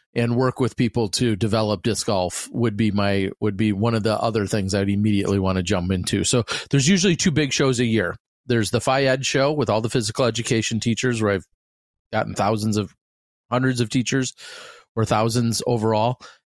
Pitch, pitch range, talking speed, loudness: 115 Hz, 105-125 Hz, 195 wpm, -21 LUFS